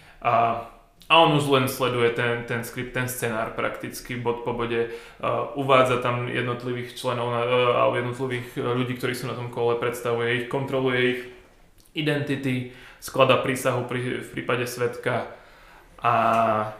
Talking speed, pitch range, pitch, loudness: 145 wpm, 120-130 Hz, 125 Hz, -24 LUFS